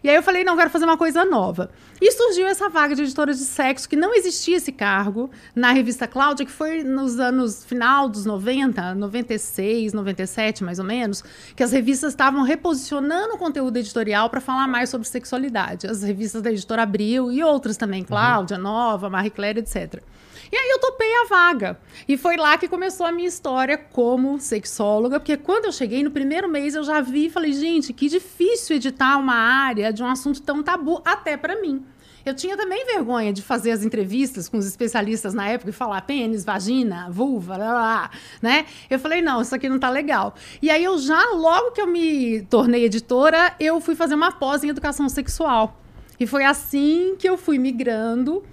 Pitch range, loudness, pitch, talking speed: 230-320 Hz, -21 LUFS, 270 Hz, 200 wpm